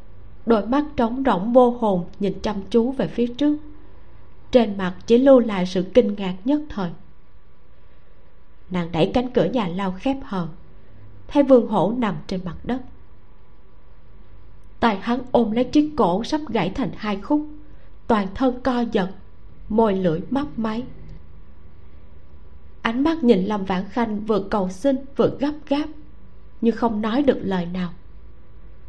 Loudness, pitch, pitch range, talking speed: -21 LUFS, 220 Hz, 180-255 Hz, 155 wpm